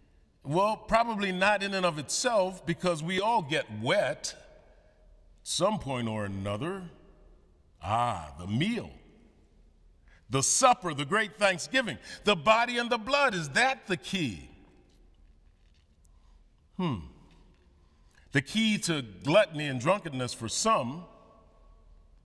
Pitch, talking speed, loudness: 135 Hz, 115 wpm, -28 LUFS